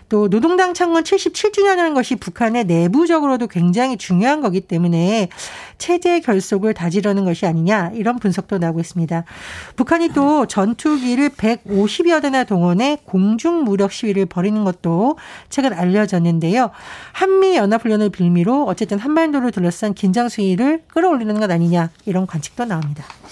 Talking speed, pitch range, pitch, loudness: 350 characters per minute, 185-285 Hz, 215 Hz, -17 LUFS